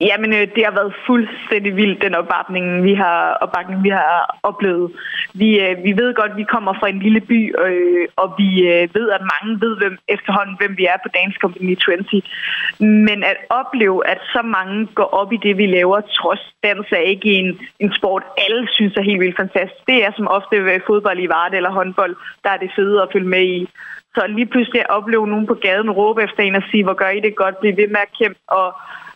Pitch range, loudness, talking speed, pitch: 190-215 Hz, -16 LUFS, 225 wpm, 200 Hz